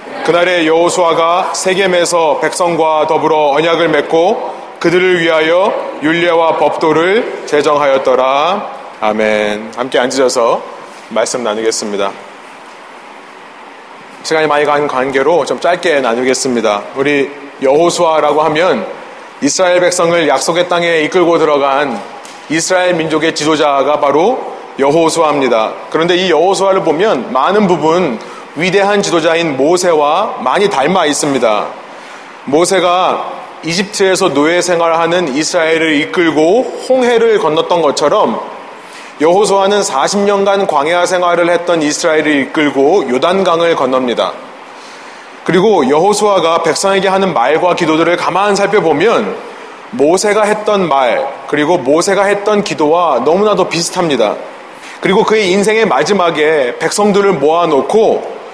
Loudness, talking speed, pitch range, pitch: -11 LUFS, 295 characters per minute, 150-185 Hz, 170 Hz